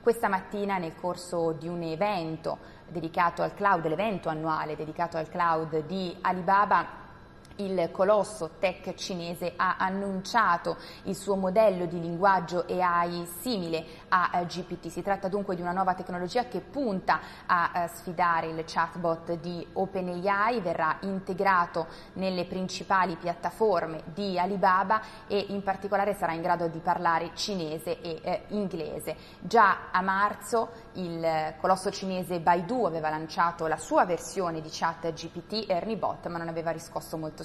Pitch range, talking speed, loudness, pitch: 165-195 Hz, 140 wpm, -29 LUFS, 175 Hz